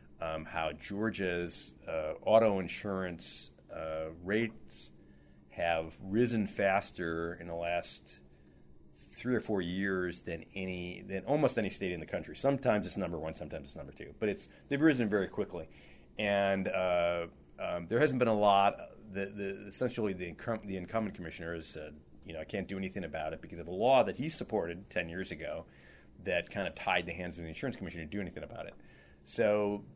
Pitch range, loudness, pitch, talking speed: 80-100 Hz, -34 LUFS, 90 Hz, 185 wpm